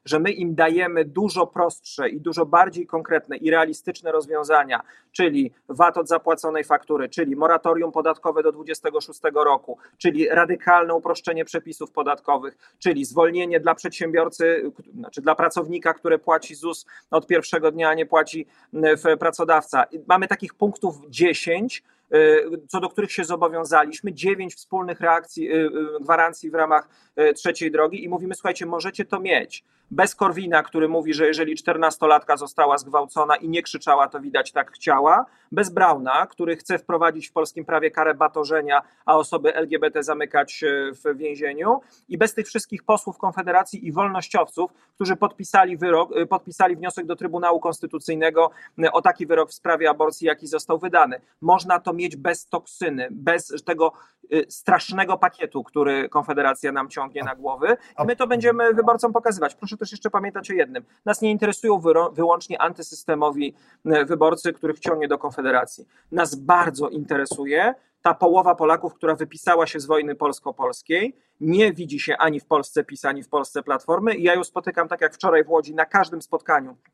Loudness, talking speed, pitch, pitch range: -21 LUFS, 155 wpm, 165 Hz, 155-185 Hz